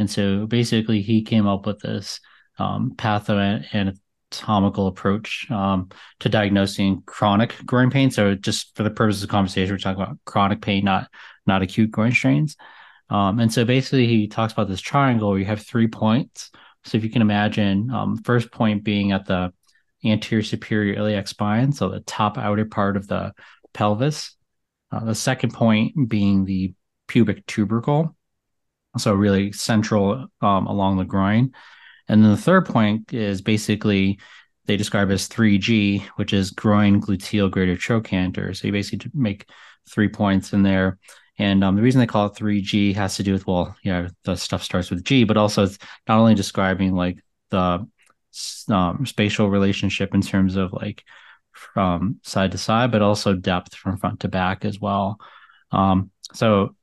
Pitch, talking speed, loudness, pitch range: 105 Hz, 170 wpm, -21 LUFS, 95-110 Hz